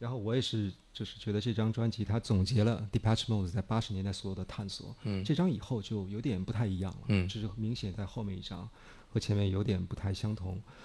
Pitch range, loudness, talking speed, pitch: 100-115 Hz, -34 LUFS, 385 characters per minute, 110 Hz